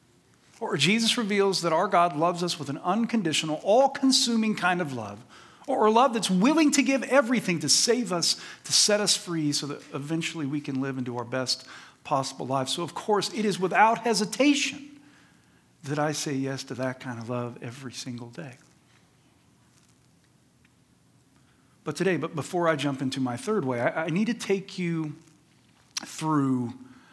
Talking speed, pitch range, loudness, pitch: 170 wpm, 135-215 Hz, -25 LUFS, 165 Hz